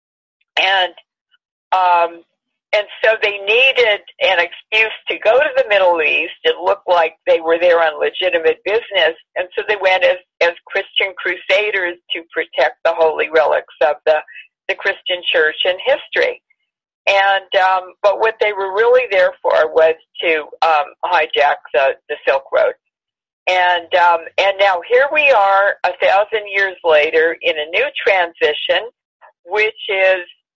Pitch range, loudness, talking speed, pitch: 175-270 Hz, -15 LUFS, 150 wpm, 195 Hz